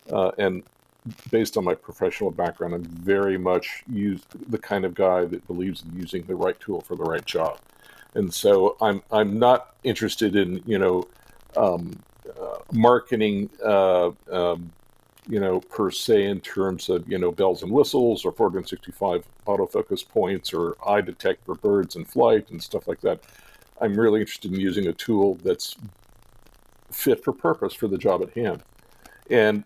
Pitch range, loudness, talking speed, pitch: 90-115 Hz, -24 LUFS, 170 wpm, 100 Hz